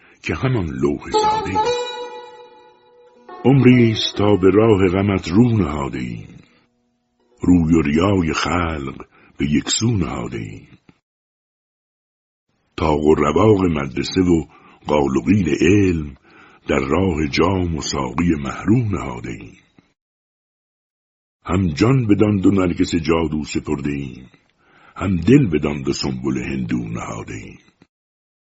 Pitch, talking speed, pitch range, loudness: 95 Hz, 110 wpm, 75-120 Hz, -18 LUFS